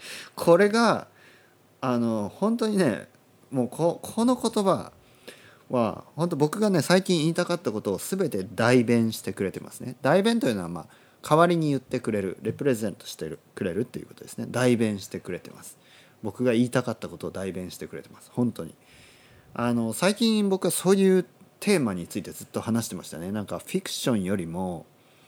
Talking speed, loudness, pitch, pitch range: 370 characters per minute, -26 LUFS, 125 Hz, 115-185 Hz